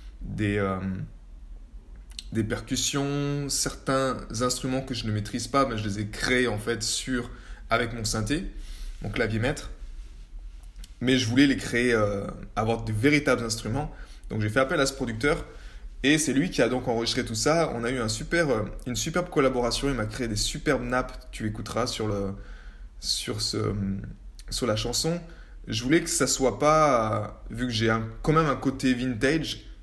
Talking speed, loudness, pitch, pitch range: 180 wpm, -26 LUFS, 115 Hz, 105-130 Hz